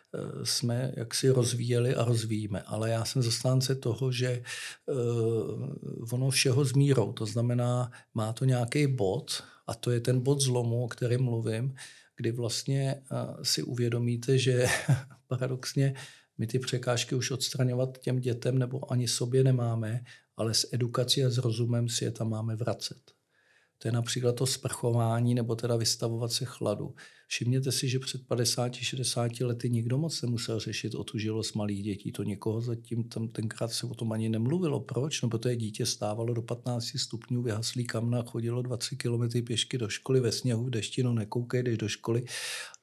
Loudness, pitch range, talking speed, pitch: -30 LUFS, 115-130 Hz, 160 wpm, 120 Hz